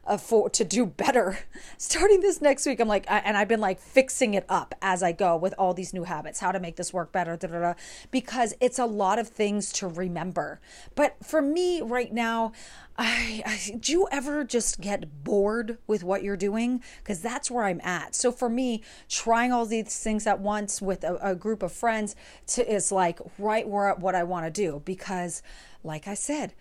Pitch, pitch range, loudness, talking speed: 210 Hz, 185-240 Hz, -27 LUFS, 210 wpm